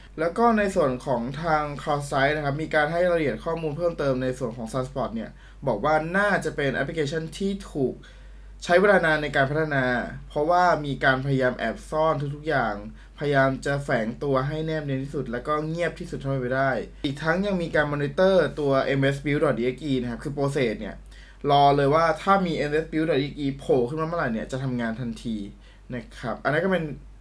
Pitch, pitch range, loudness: 145 Hz, 135-160 Hz, -24 LUFS